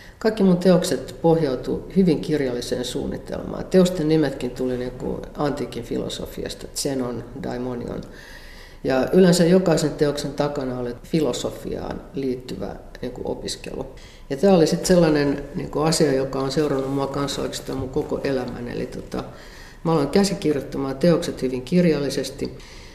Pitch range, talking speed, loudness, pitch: 130-165 Hz, 120 wpm, -22 LUFS, 140 Hz